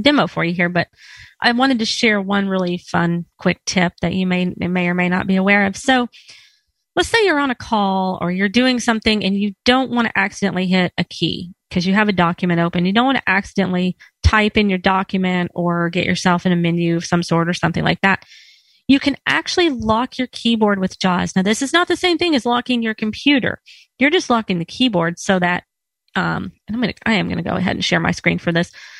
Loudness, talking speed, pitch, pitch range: -17 LUFS, 240 wpm, 195 Hz, 180-245 Hz